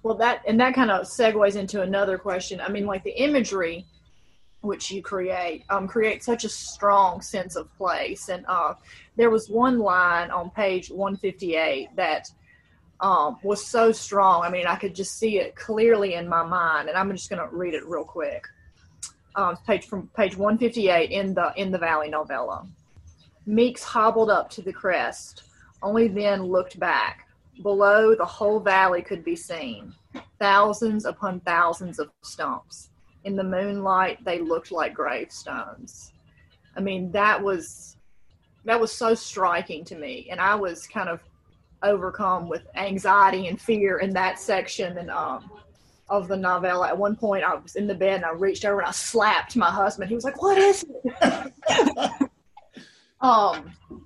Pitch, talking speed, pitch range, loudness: 195 Hz, 170 wpm, 180-220 Hz, -23 LUFS